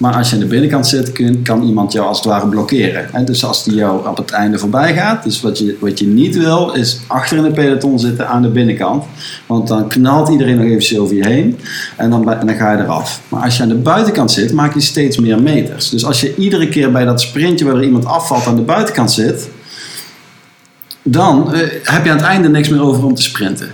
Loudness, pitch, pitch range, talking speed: -12 LUFS, 125 Hz, 110-145 Hz, 240 wpm